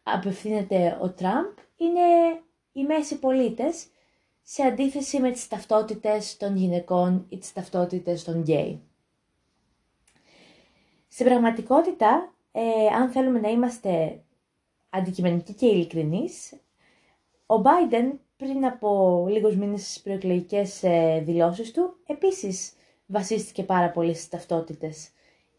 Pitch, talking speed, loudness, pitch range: 210 Hz, 105 wpm, -24 LUFS, 180-260 Hz